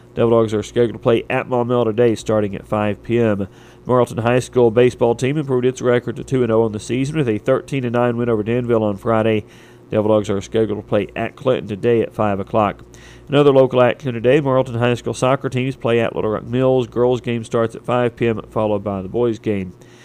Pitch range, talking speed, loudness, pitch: 110-125 Hz, 215 wpm, -18 LUFS, 120 Hz